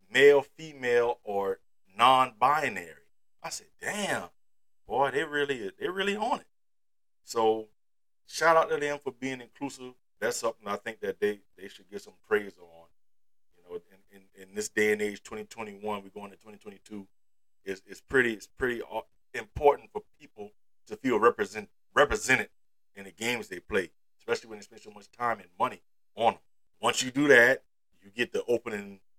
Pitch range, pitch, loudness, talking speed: 100-145 Hz, 110 Hz, -28 LUFS, 180 wpm